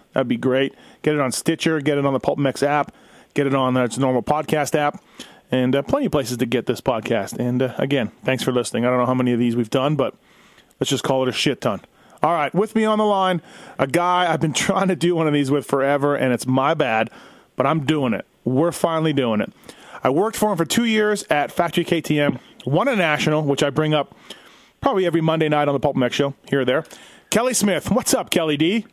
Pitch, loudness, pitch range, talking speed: 145 Hz, -20 LUFS, 130-175 Hz, 250 wpm